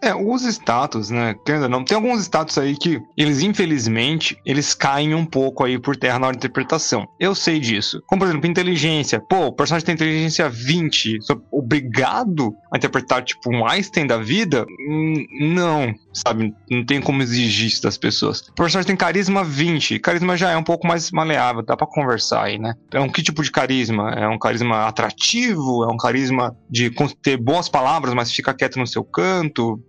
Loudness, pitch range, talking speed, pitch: -19 LUFS, 120-165 Hz, 185 wpm, 140 Hz